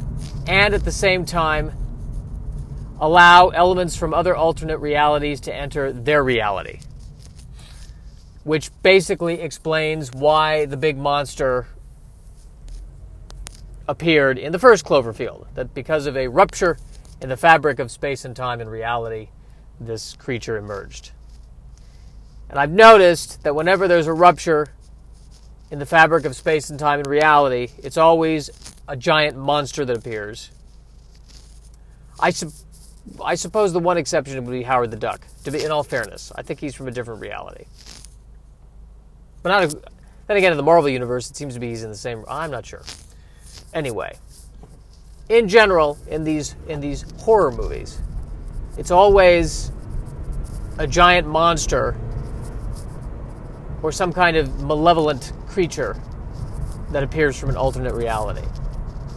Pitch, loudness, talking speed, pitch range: 145 Hz, -18 LUFS, 140 wpm, 120-160 Hz